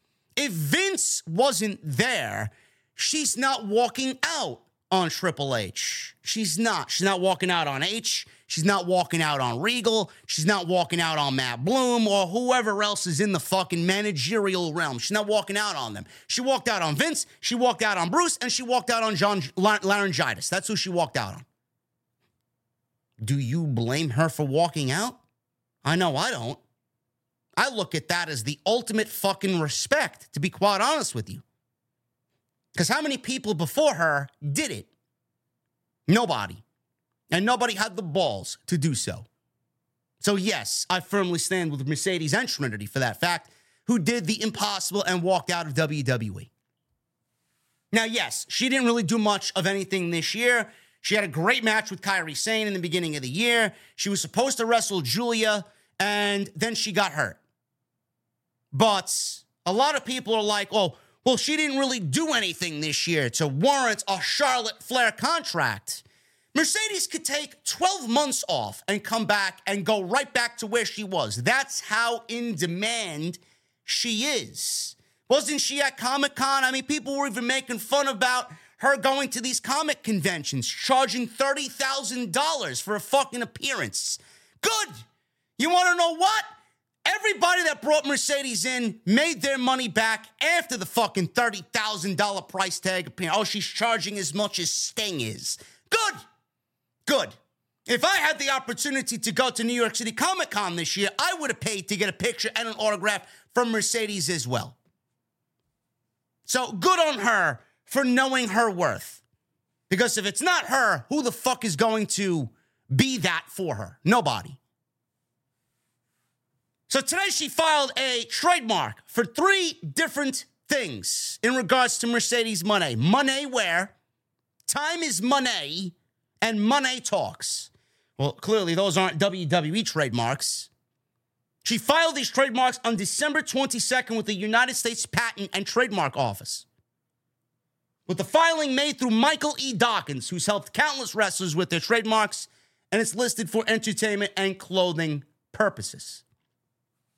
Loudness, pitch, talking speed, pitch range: -25 LUFS, 210 Hz, 160 wpm, 170-250 Hz